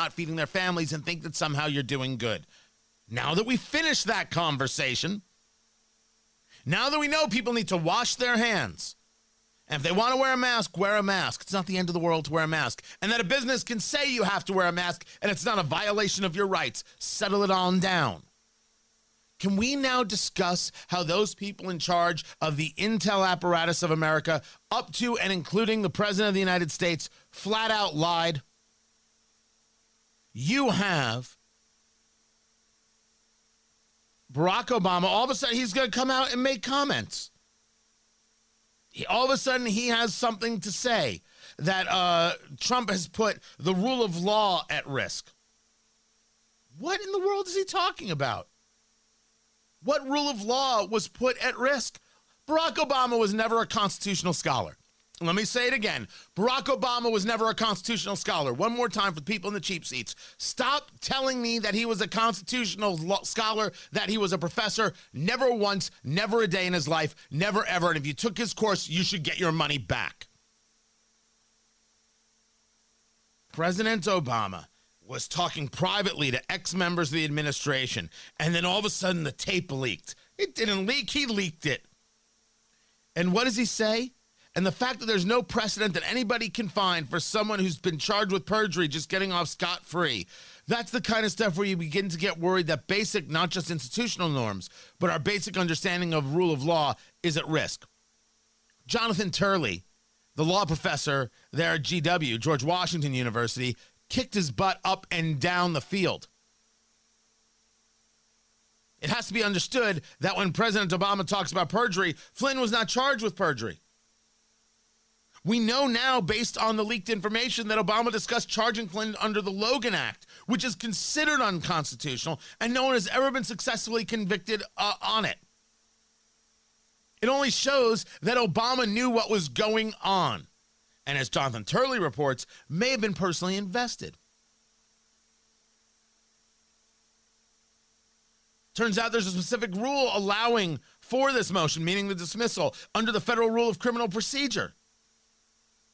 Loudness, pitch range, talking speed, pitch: -27 LUFS, 170-230 Hz, 170 wpm, 200 Hz